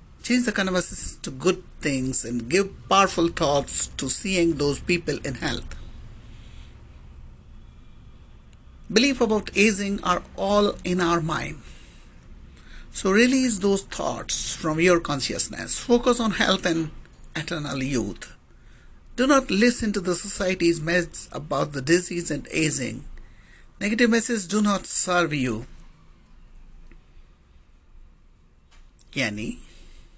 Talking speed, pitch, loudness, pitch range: 110 wpm, 170 Hz, -18 LUFS, 120-200 Hz